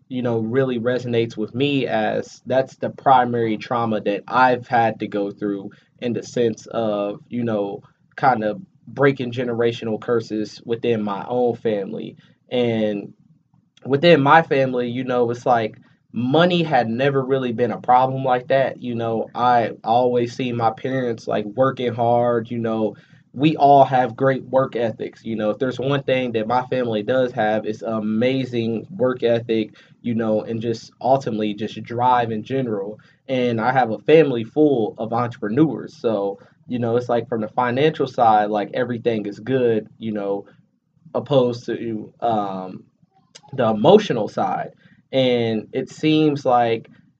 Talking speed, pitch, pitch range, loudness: 160 wpm, 120 Hz, 110-130 Hz, -20 LUFS